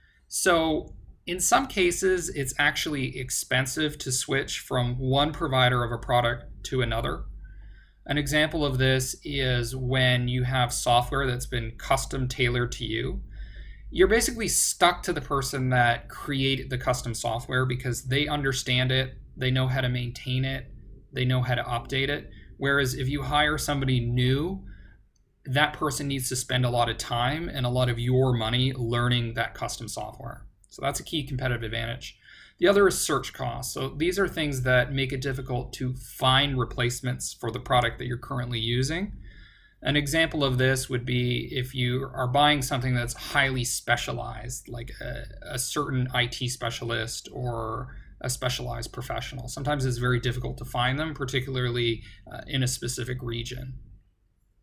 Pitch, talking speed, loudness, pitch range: 125 Hz, 165 wpm, -26 LUFS, 120-135 Hz